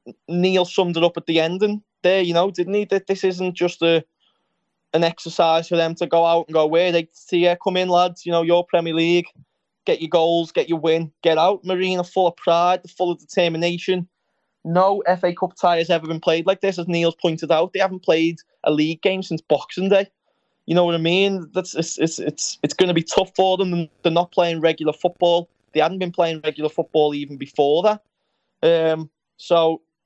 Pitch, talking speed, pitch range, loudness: 175 Hz, 220 wpm, 165-185 Hz, -20 LUFS